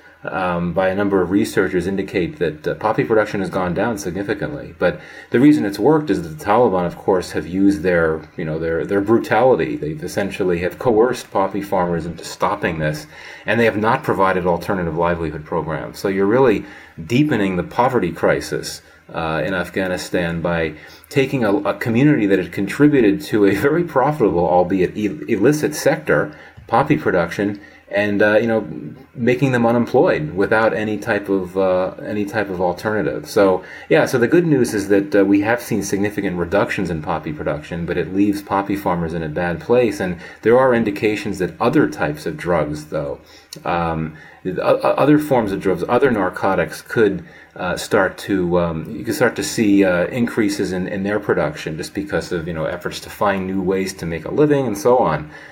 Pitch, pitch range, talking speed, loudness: 100 Hz, 85-105 Hz, 185 wpm, -18 LUFS